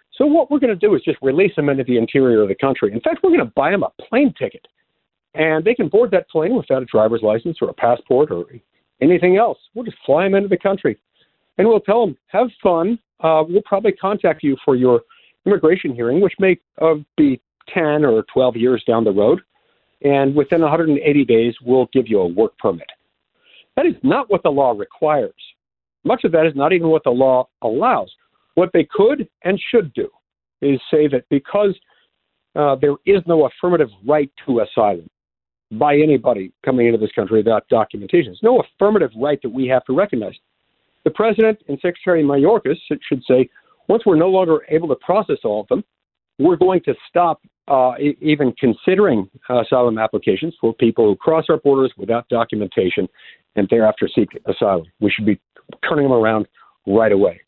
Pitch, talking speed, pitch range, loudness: 150 Hz, 195 wpm, 125-195 Hz, -17 LUFS